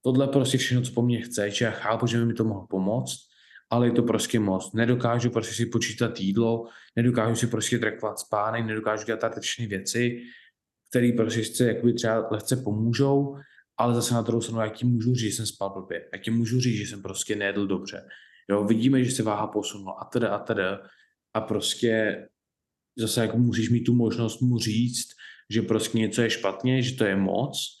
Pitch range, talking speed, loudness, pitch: 110-120 Hz, 200 wpm, -26 LUFS, 115 Hz